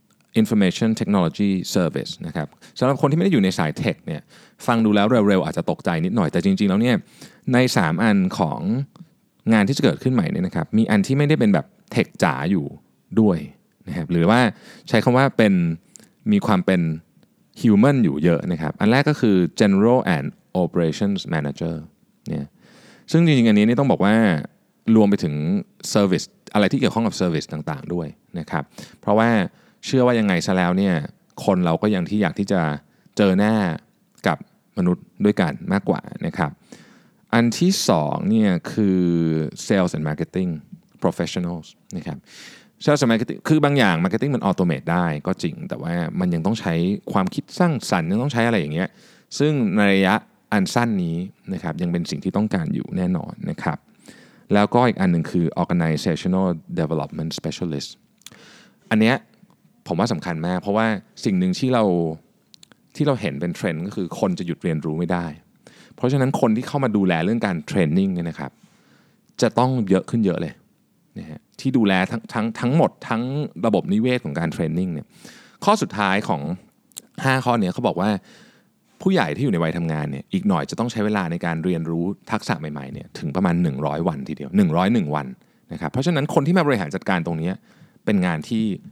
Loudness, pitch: -21 LUFS, 110 Hz